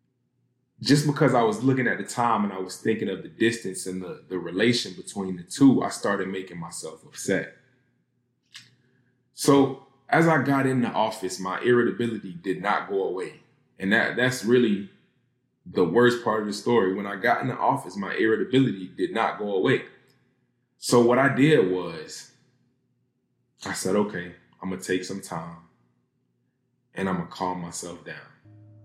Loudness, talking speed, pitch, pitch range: -24 LUFS, 175 wpm, 110 Hz, 95-125 Hz